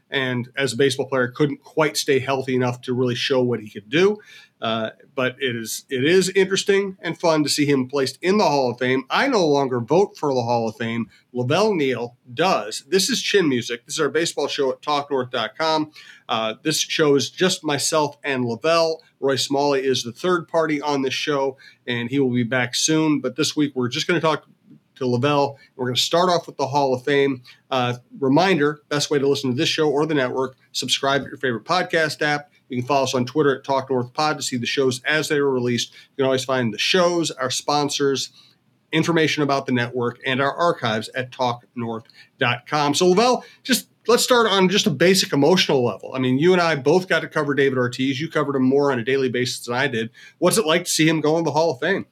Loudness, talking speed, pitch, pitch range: -21 LUFS, 225 wpm, 140 Hz, 130-155 Hz